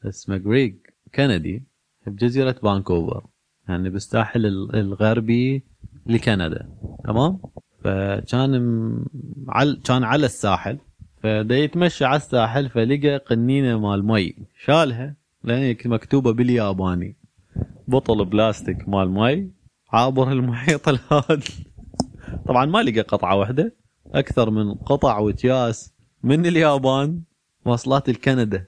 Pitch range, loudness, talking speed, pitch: 105-135 Hz, -21 LUFS, 100 wpm, 120 Hz